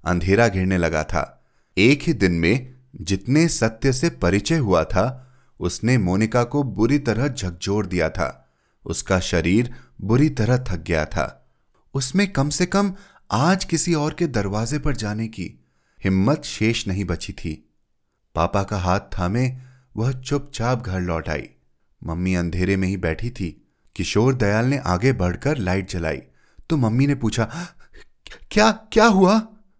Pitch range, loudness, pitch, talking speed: 90-135 Hz, -21 LUFS, 110 Hz, 150 wpm